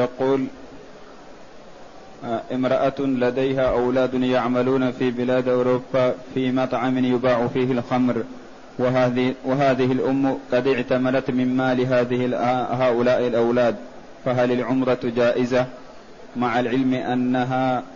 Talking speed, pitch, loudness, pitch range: 90 wpm, 125 Hz, -21 LUFS, 125-130 Hz